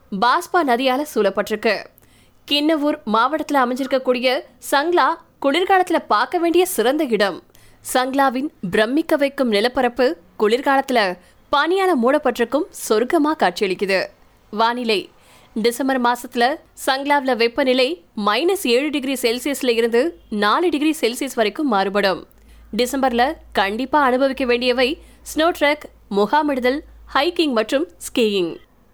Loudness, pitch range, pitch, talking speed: -19 LUFS, 230-300 Hz, 260 Hz, 95 wpm